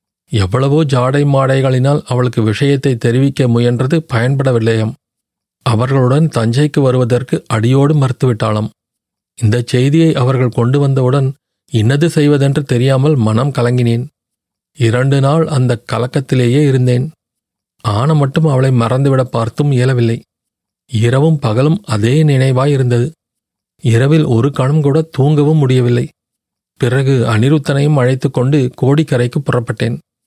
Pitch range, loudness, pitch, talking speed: 120-145 Hz, -13 LUFS, 130 Hz, 100 wpm